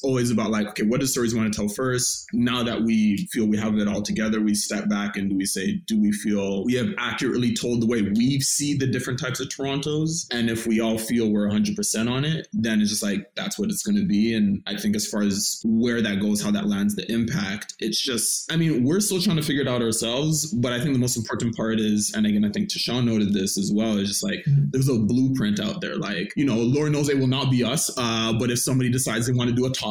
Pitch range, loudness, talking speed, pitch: 110-150 Hz, -23 LUFS, 270 wpm, 125 Hz